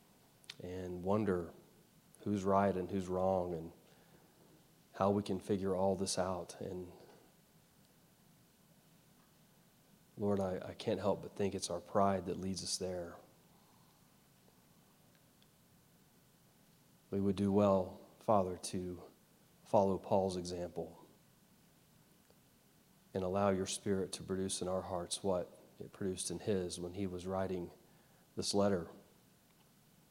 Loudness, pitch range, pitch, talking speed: -37 LUFS, 90-100 Hz, 95 Hz, 120 wpm